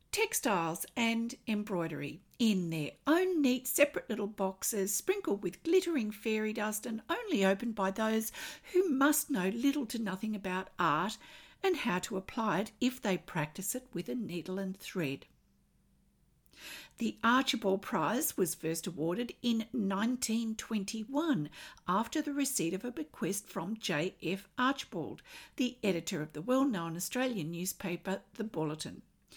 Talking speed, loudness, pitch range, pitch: 140 wpm, -34 LUFS, 185-255 Hz, 215 Hz